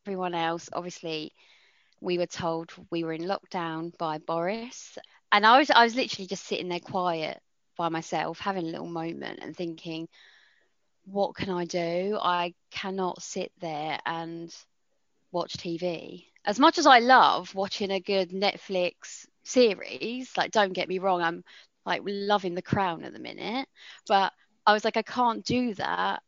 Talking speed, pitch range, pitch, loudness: 165 wpm, 170-205 Hz, 185 Hz, -27 LUFS